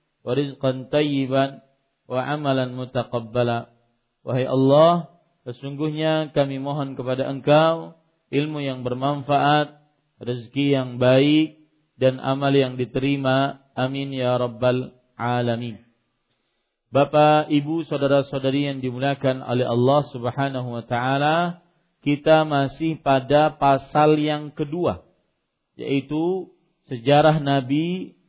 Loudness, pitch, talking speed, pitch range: -22 LUFS, 140 Hz, 100 wpm, 130-150 Hz